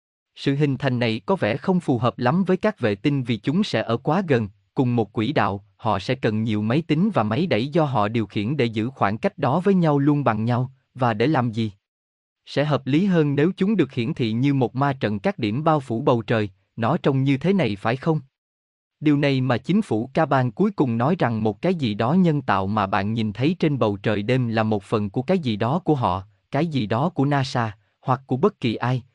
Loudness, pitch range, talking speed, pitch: -22 LUFS, 110-150 Hz, 245 wpm, 125 Hz